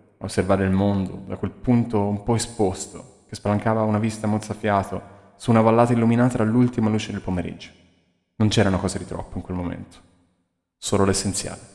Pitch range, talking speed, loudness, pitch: 90-110 Hz, 165 wpm, -22 LUFS, 100 Hz